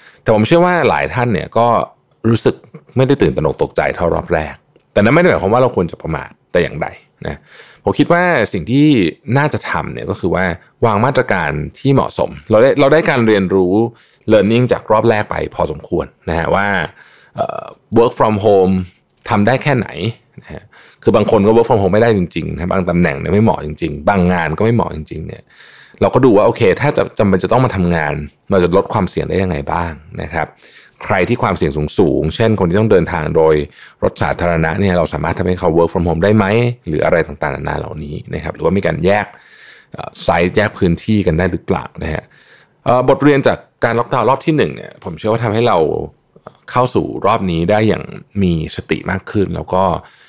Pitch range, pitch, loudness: 85-120 Hz, 100 Hz, -14 LUFS